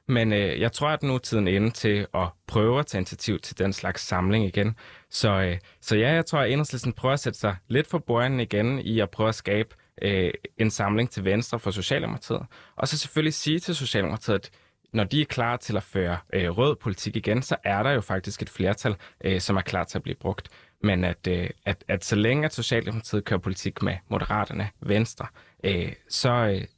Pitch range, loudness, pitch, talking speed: 95-120 Hz, -26 LUFS, 105 Hz, 220 wpm